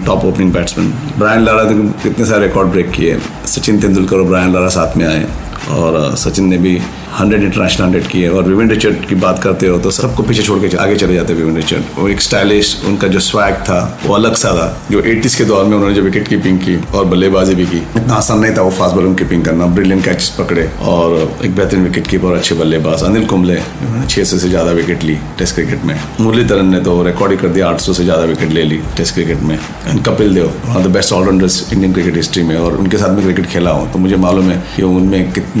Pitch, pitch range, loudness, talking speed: 95 Hz, 85-100 Hz, -11 LUFS, 235 wpm